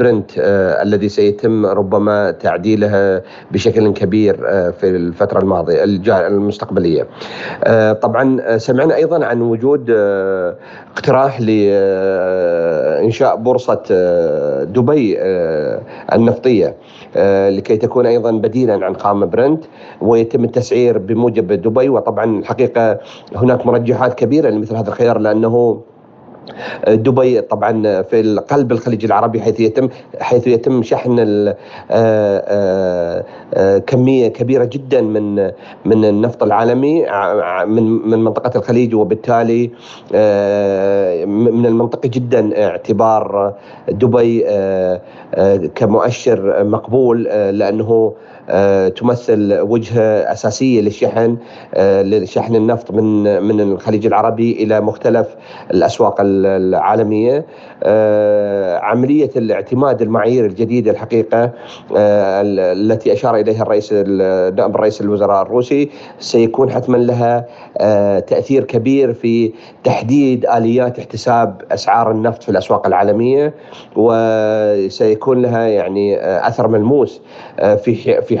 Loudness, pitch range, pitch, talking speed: -14 LUFS, 105-120 Hz, 115 Hz, 105 wpm